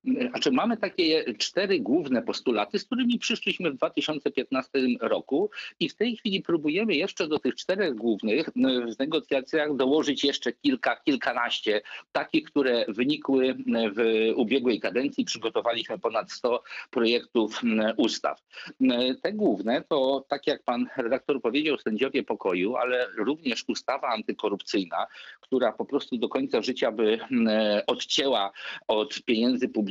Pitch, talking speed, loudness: 135 Hz, 125 wpm, -27 LUFS